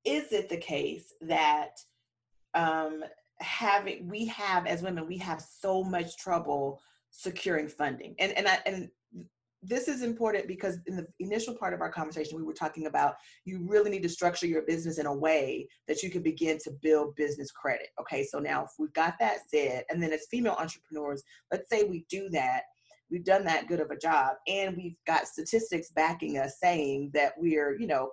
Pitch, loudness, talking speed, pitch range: 170 Hz, -31 LUFS, 195 wpm, 155-195 Hz